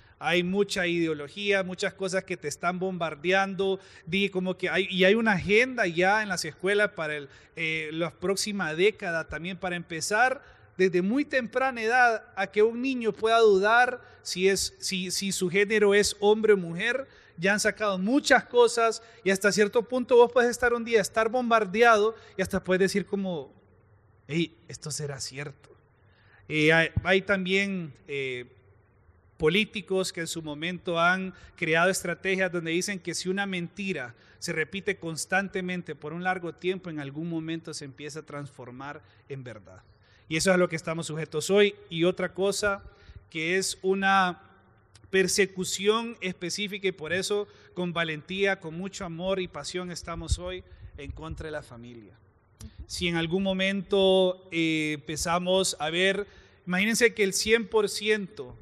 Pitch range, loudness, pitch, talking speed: 155-200 Hz, -26 LUFS, 185 Hz, 160 wpm